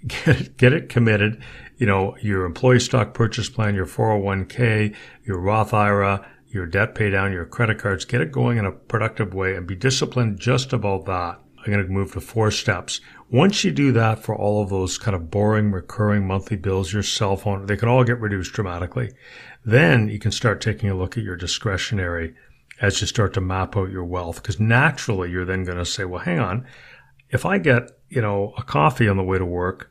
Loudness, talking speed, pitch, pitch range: -21 LUFS, 215 wpm, 105 Hz, 95-120 Hz